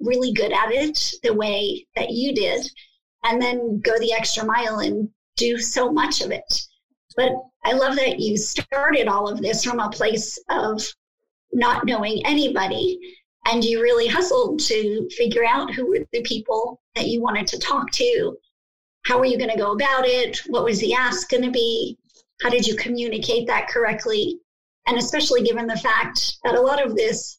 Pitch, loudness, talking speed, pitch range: 245 Hz, -21 LUFS, 185 wpm, 230-295 Hz